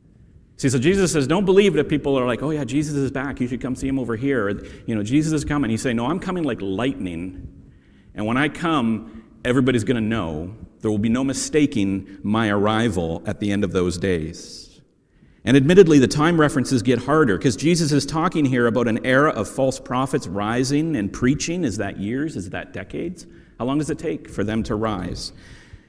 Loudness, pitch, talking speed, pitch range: -21 LUFS, 130 Hz, 210 wpm, 105-145 Hz